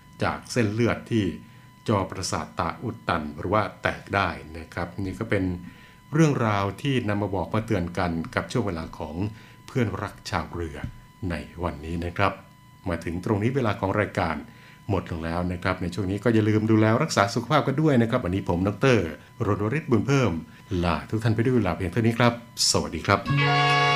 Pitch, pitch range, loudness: 105 Hz, 90-120 Hz, -25 LUFS